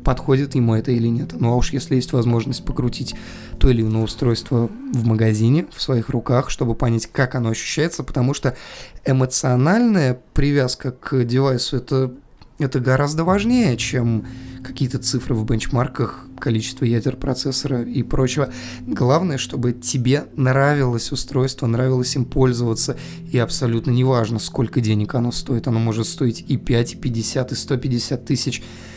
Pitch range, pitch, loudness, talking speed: 120-135 Hz, 130 Hz, -20 LUFS, 145 wpm